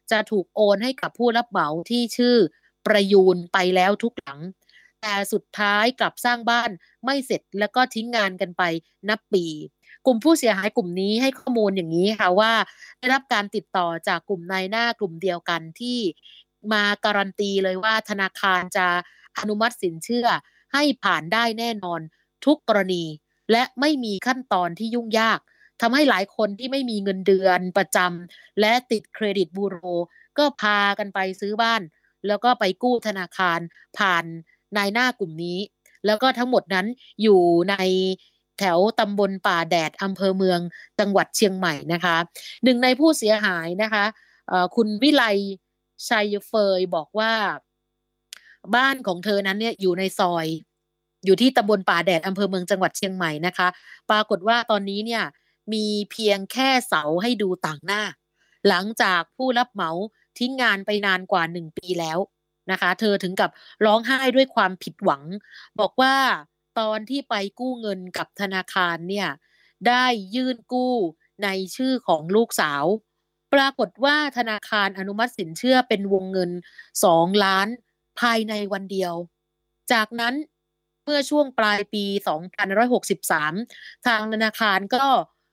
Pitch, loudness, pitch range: 205 Hz, -22 LUFS, 185-235 Hz